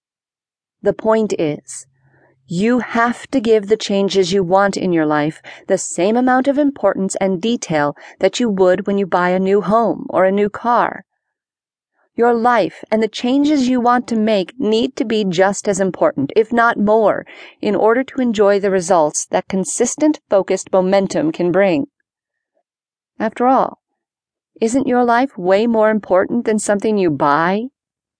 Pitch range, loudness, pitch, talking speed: 190-240 Hz, -16 LUFS, 210 Hz, 160 wpm